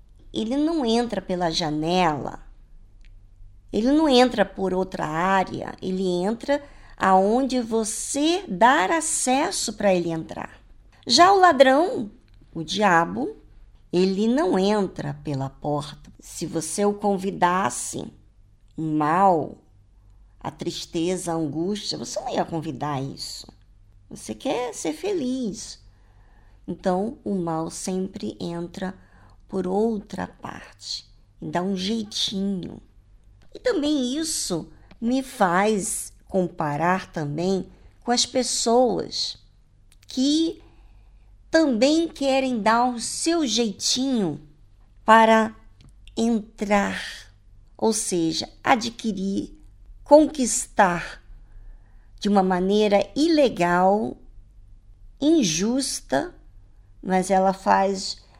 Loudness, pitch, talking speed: -23 LUFS, 185 Hz, 95 wpm